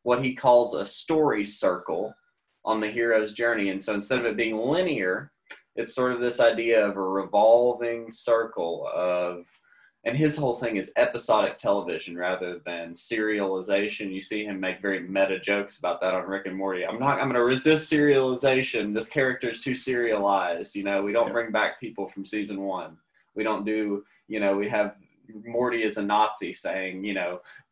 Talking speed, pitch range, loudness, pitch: 185 wpm, 100-120 Hz, -26 LUFS, 105 Hz